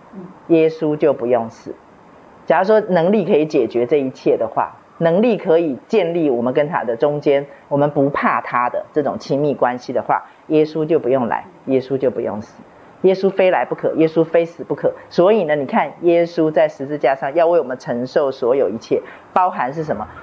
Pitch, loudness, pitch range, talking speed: 160 Hz, -17 LUFS, 140-175 Hz, 290 characters per minute